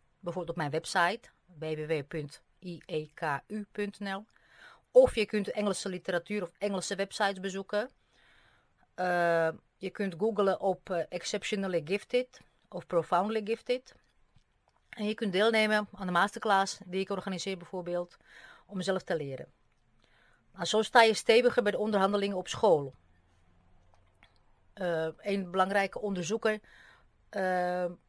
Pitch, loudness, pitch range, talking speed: 190 Hz, -31 LUFS, 170-210 Hz, 115 wpm